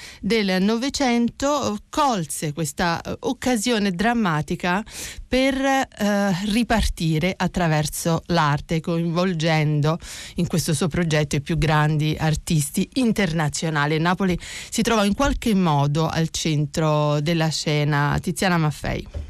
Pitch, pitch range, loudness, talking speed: 175 Hz, 155-210 Hz, -22 LUFS, 105 wpm